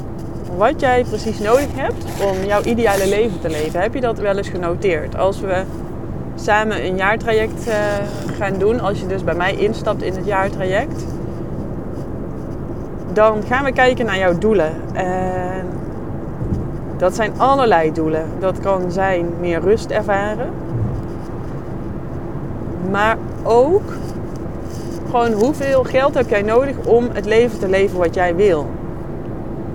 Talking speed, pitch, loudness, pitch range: 135 wpm, 210 Hz, -18 LUFS, 185-240 Hz